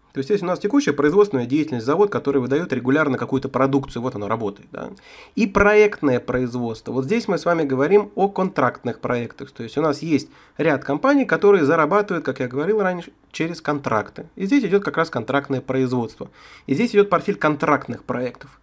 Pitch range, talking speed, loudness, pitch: 130-185 Hz, 185 wpm, -20 LUFS, 145 Hz